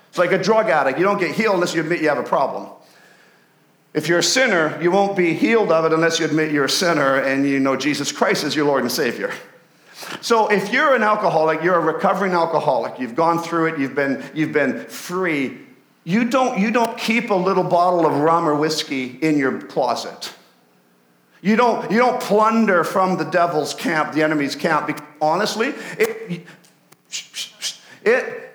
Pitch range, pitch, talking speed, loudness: 150-210 Hz, 170 Hz, 190 wpm, -19 LUFS